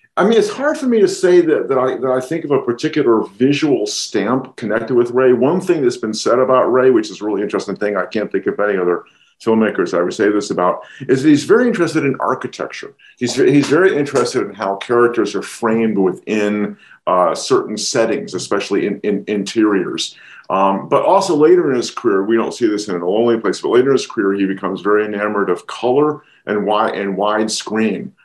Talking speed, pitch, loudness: 215 wpm, 130 Hz, -16 LUFS